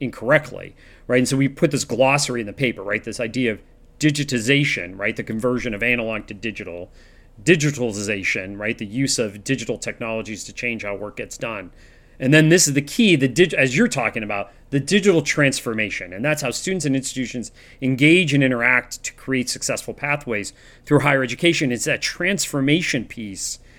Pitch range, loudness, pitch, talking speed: 110-145 Hz, -20 LUFS, 125 Hz, 180 wpm